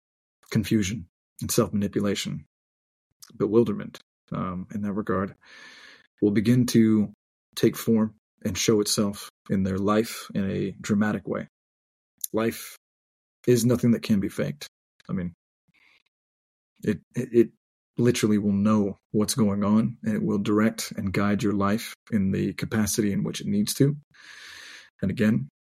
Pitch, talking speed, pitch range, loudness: 105 Hz, 140 wpm, 100-115 Hz, -25 LUFS